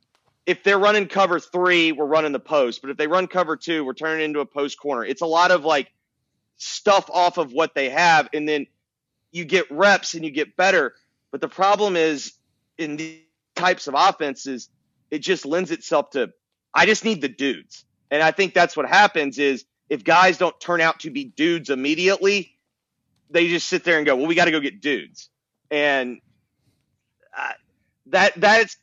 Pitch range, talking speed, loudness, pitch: 140-180 Hz, 195 wpm, -20 LUFS, 160 Hz